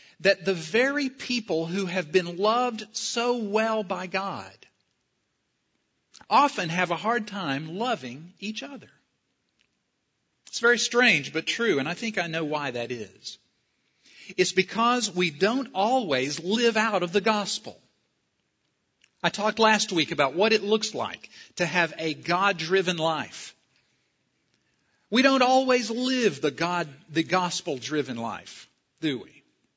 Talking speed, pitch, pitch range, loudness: 135 wpm, 195 Hz, 165-225 Hz, -25 LUFS